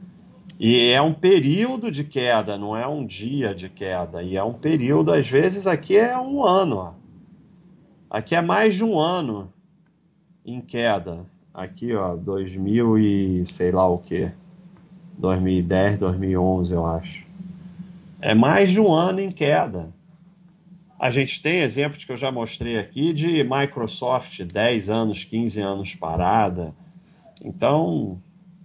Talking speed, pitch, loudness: 140 wpm, 140 Hz, -21 LUFS